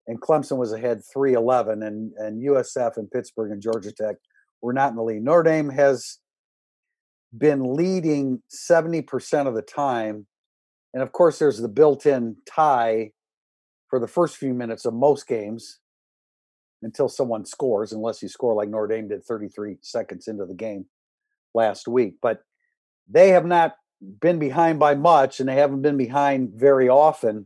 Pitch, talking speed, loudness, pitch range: 130 Hz, 160 wpm, -21 LUFS, 110-155 Hz